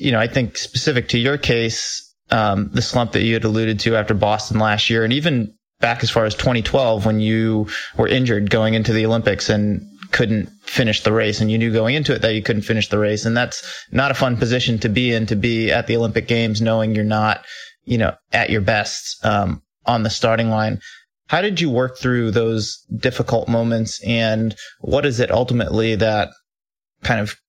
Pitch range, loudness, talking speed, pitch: 110-120 Hz, -18 LUFS, 210 wpm, 115 Hz